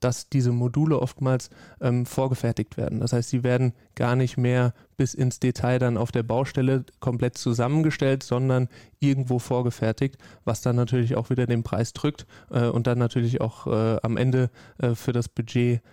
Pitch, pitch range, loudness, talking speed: 125 Hz, 120-130 Hz, -25 LUFS, 175 wpm